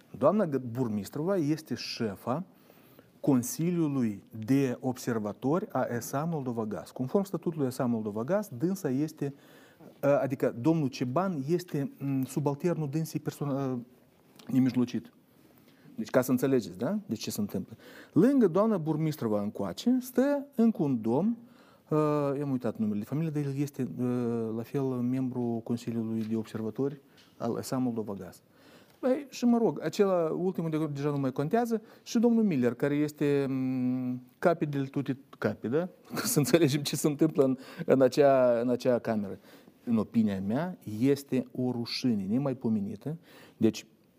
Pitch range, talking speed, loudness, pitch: 125-175 Hz, 140 wpm, -30 LUFS, 140 Hz